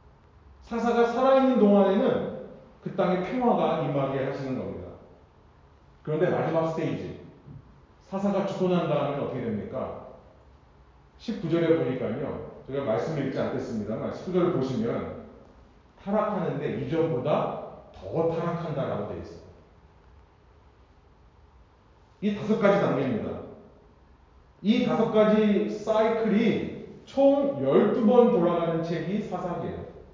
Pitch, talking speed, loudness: 165 Hz, 255 characters per minute, -26 LUFS